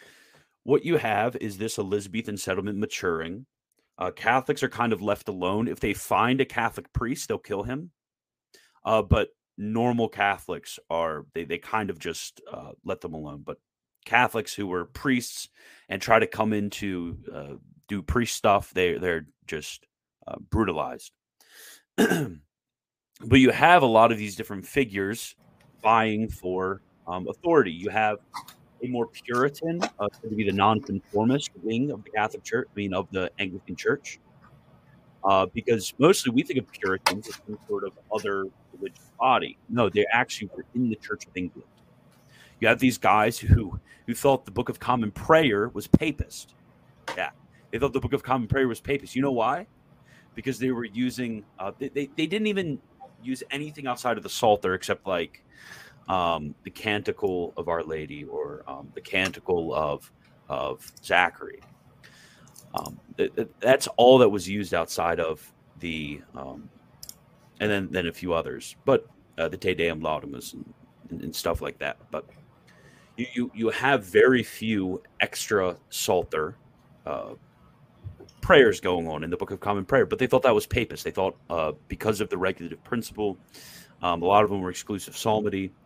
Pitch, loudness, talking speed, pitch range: 110 Hz, -26 LUFS, 170 wpm, 95-130 Hz